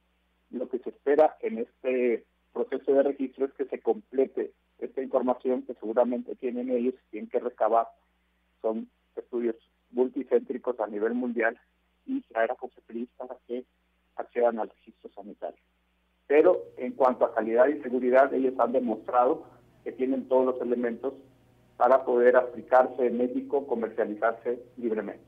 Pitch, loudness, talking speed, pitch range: 125 Hz, -27 LUFS, 140 wpm, 115-130 Hz